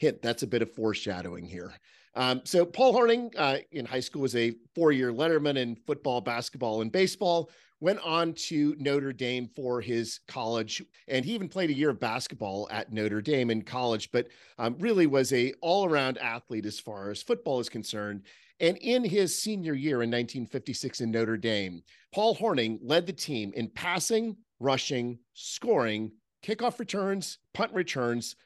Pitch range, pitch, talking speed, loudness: 115-170 Hz, 130 Hz, 170 wpm, -29 LUFS